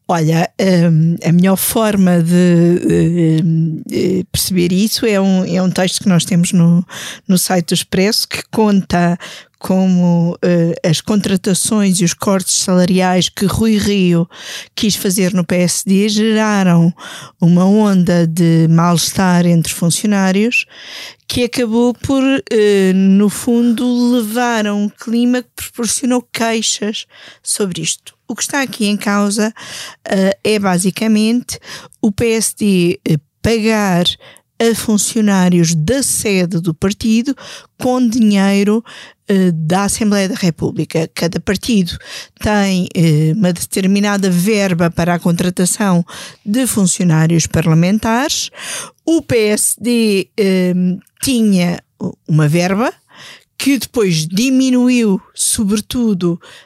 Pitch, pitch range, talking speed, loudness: 195 Hz, 175-220 Hz, 110 wpm, -14 LUFS